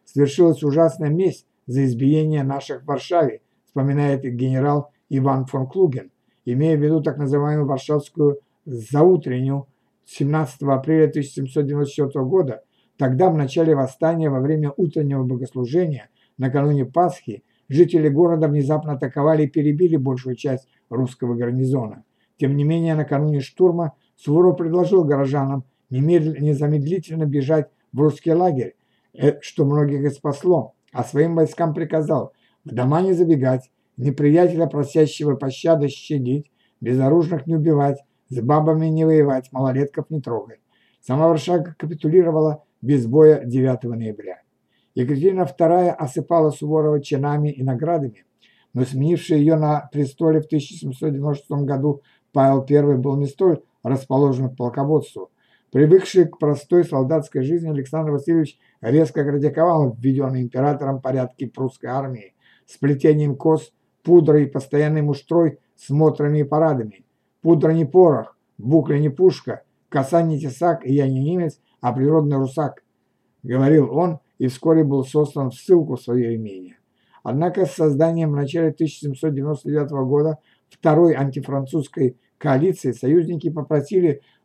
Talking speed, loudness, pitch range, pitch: 125 wpm, -19 LUFS, 135-160 Hz, 145 Hz